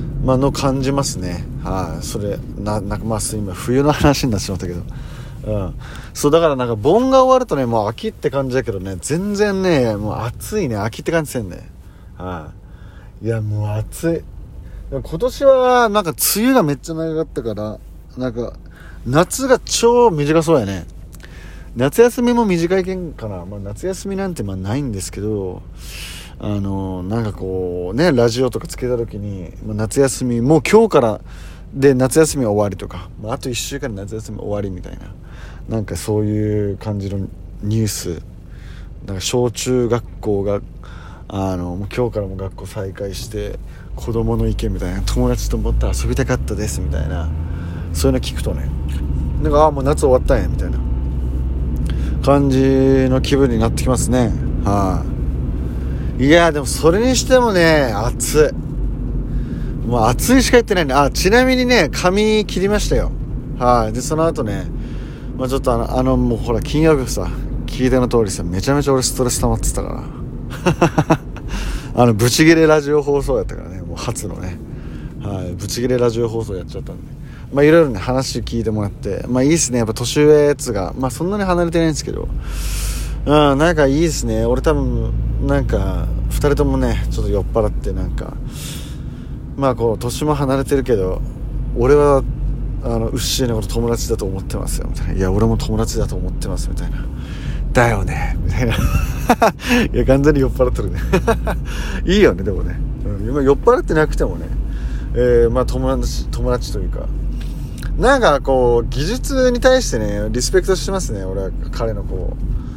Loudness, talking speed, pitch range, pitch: -17 LUFS, 340 characters per minute, 95-140 Hz, 120 Hz